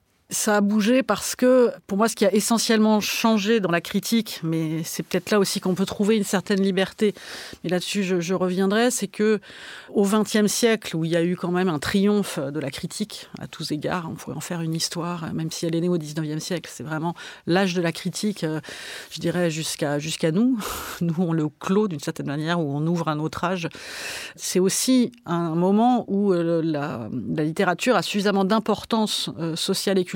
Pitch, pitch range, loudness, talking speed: 185 Hz, 165-210 Hz, -23 LUFS, 205 wpm